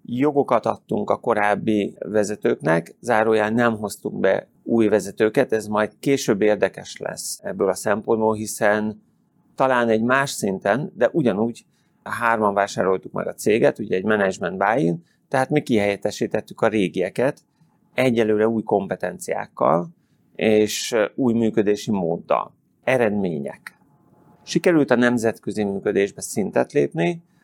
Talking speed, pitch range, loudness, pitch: 120 wpm, 105-120 Hz, -21 LUFS, 110 Hz